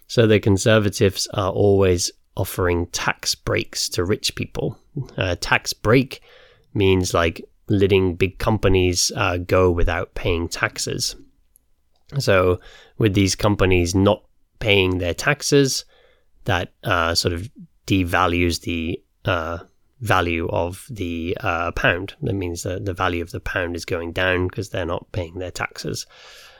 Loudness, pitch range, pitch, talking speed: -21 LUFS, 85-100 Hz, 95 Hz, 140 wpm